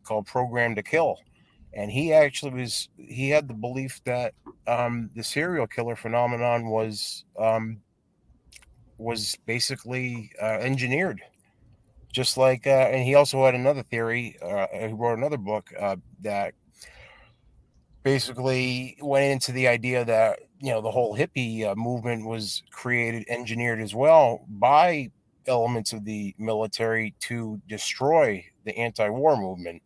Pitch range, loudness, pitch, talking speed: 110-130 Hz, -25 LUFS, 120 Hz, 135 wpm